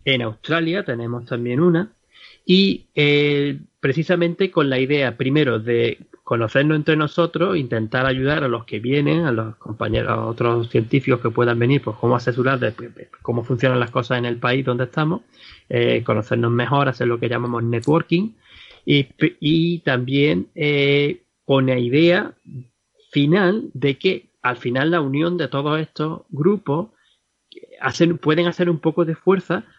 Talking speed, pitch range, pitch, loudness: 160 wpm, 120-165 Hz, 140 Hz, -20 LUFS